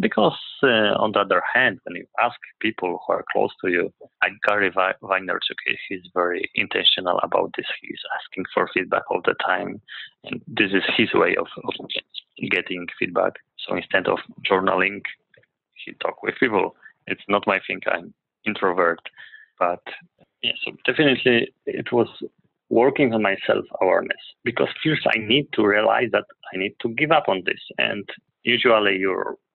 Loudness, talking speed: -22 LUFS, 160 wpm